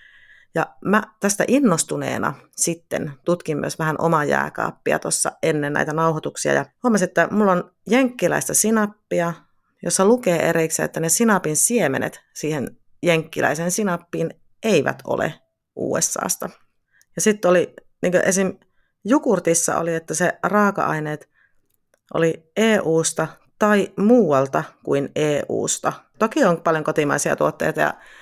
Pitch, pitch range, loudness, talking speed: 175 Hz, 160-210 Hz, -20 LUFS, 120 wpm